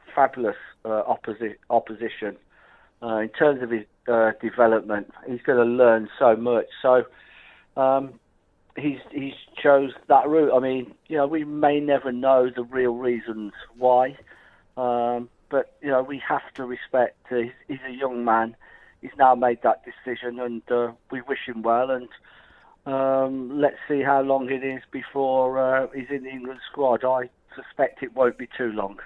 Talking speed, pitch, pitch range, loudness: 170 wpm, 125 Hz, 120-135 Hz, -23 LUFS